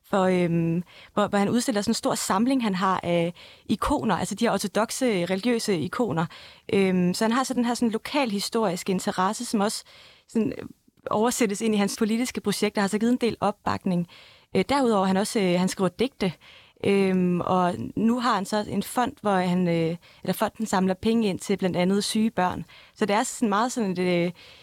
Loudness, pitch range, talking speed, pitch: -25 LUFS, 185-230 Hz, 200 wpm, 205 Hz